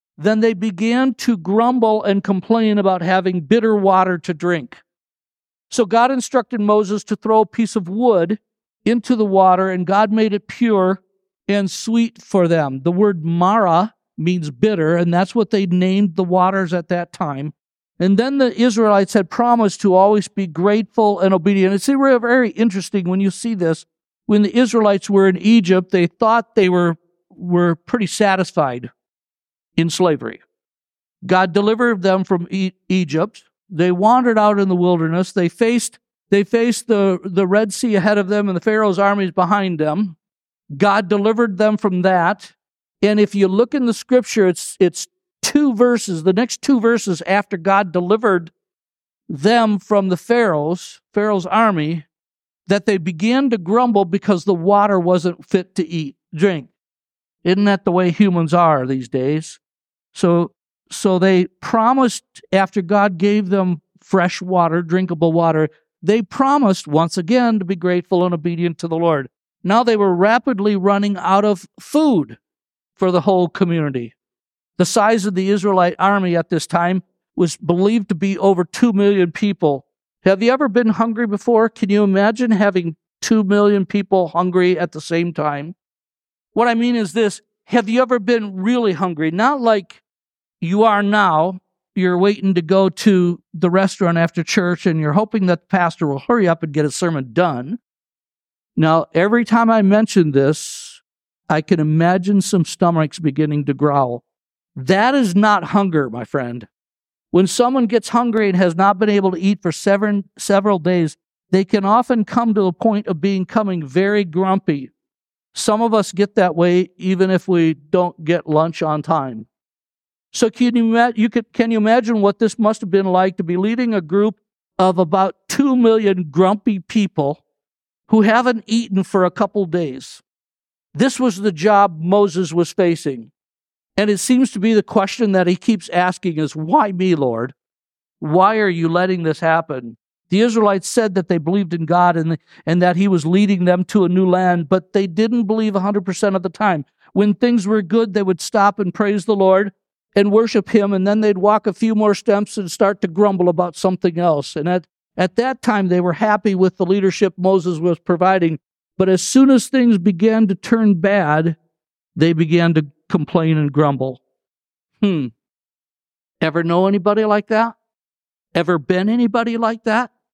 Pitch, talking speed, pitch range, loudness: 195 Hz, 175 wpm, 175-215 Hz, -16 LUFS